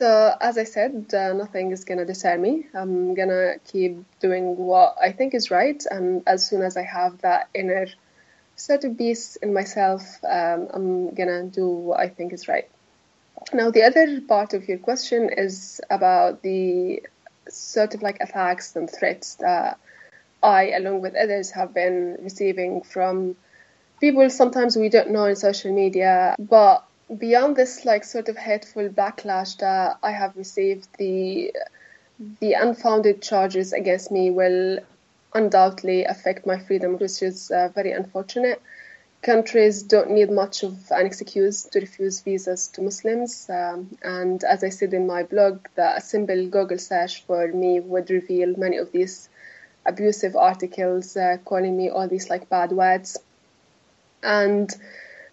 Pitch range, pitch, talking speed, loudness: 185-220 Hz, 195 Hz, 155 wpm, -22 LUFS